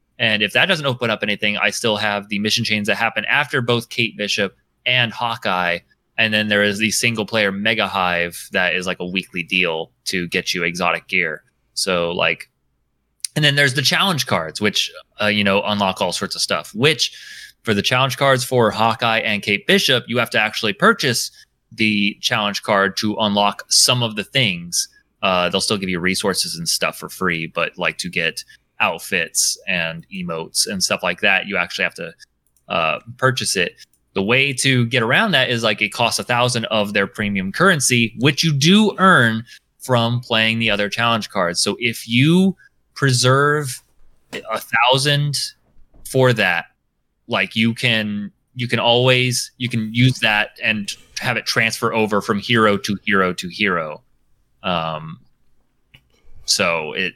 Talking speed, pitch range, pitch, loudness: 175 wpm, 105-130 Hz, 115 Hz, -18 LUFS